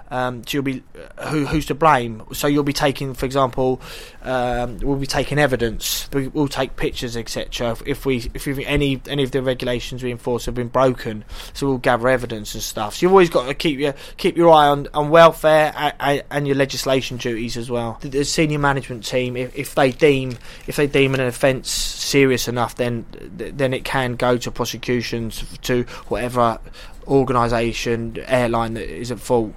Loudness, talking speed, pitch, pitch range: -20 LUFS, 185 wpm, 130 Hz, 120-140 Hz